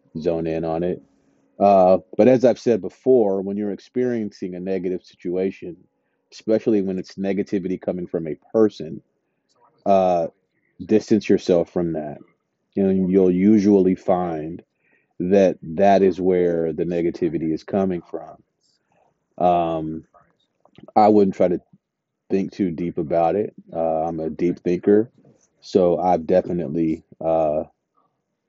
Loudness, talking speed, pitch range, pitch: -20 LUFS, 135 wpm, 85-100 Hz, 95 Hz